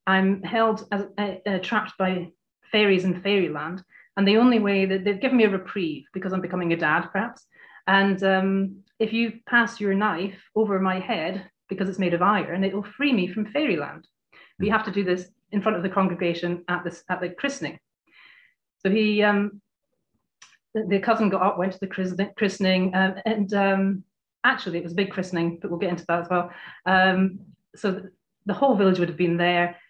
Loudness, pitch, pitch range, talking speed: -24 LUFS, 195 Hz, 185-210 Hz, 200 wpm